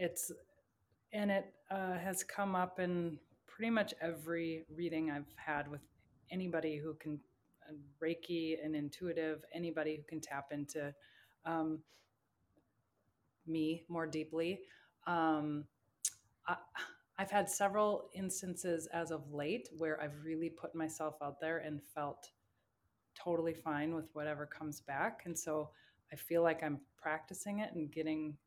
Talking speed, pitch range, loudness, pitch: 135 wpm, 150-170 Hz, -40 LUFS, 160 Hz